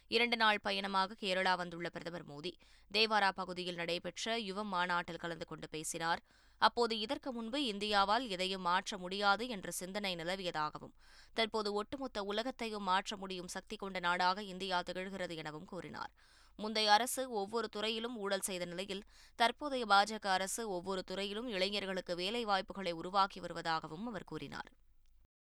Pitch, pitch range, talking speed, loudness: 195 Hz, 175-215 Hz, 130 wpm, -36 LUFS